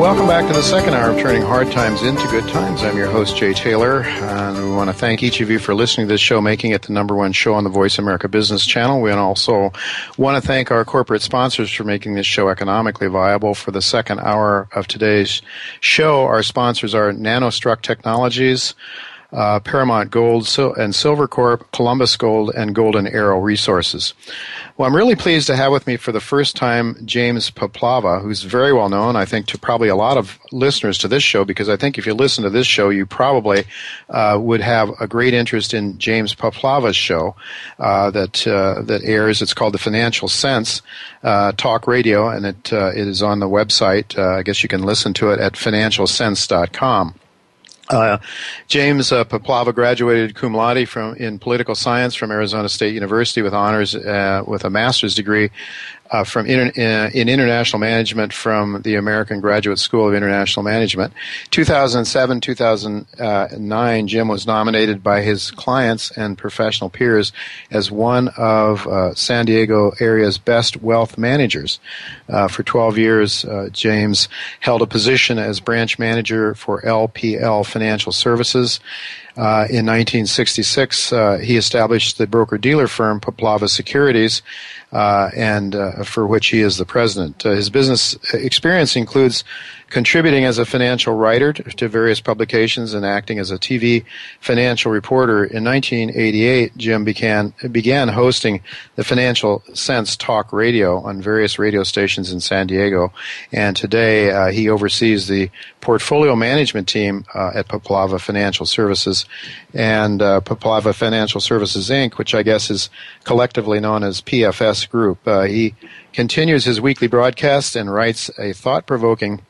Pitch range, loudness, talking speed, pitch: 105-120 Hz, -16 LUFS, 170 wpm, 110 Hz